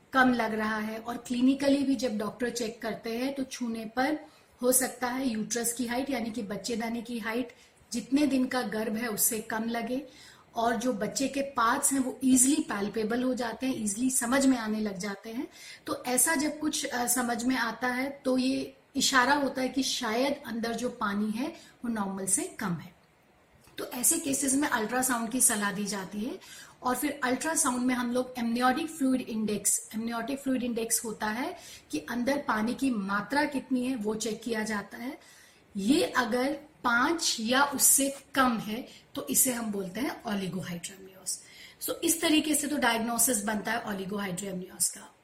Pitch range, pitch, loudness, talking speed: 225-265 Hz, 245 Hz, -29 LUFS, 180 wpm